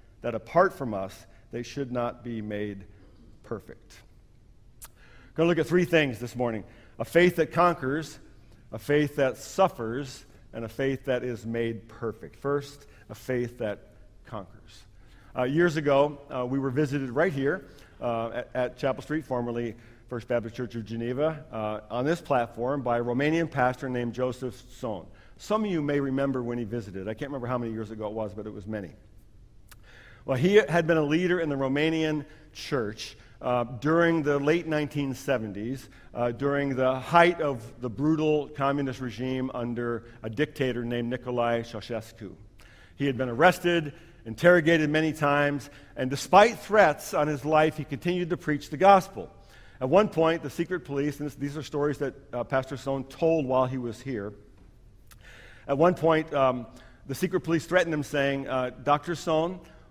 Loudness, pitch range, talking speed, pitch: -27 LUFS, 115-150 Hz, 170 wpm, 130 Hz